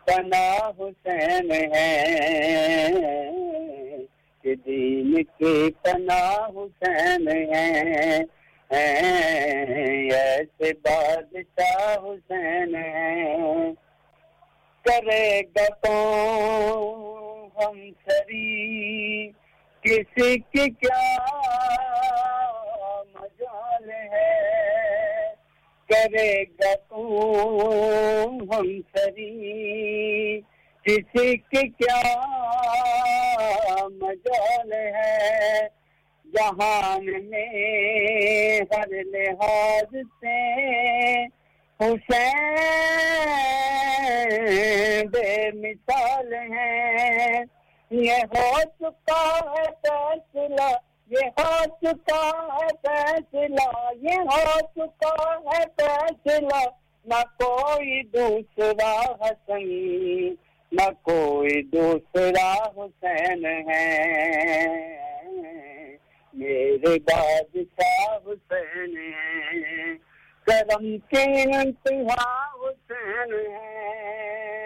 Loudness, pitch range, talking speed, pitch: -23 LUFS, 200-315 Hz, 55 wpm, 220 Hz